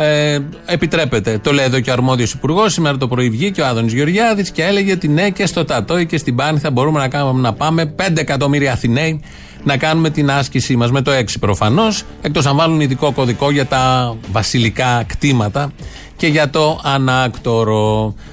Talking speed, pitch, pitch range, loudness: 185 wpm, 140 Hz, 125-160 Hz, -15 LUFS